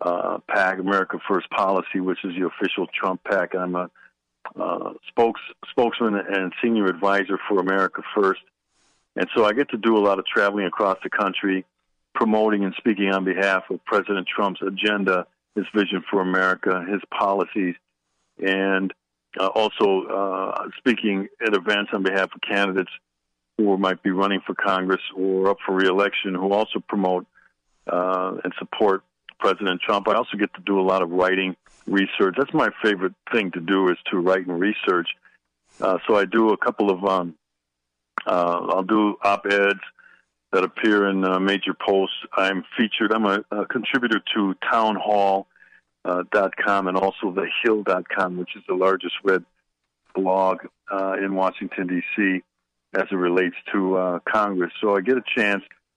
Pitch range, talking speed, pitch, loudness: 90-100 Hz, 165 wpm, 95 Hz, -22 LUFS